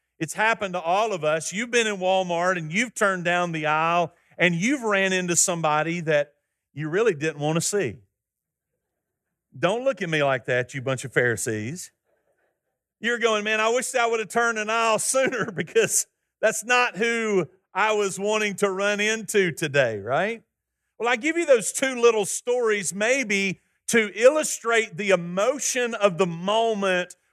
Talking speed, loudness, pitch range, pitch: 170 wpm, -23 LUFS, 170-230 Hz, 200 Hz